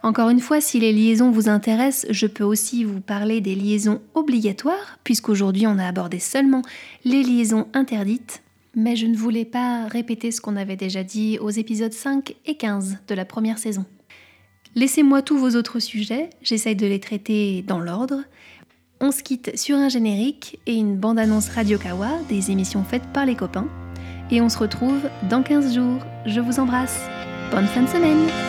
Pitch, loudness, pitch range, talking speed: 225 Hz, -21 LUFS, 205-255 Hz, 180 wpm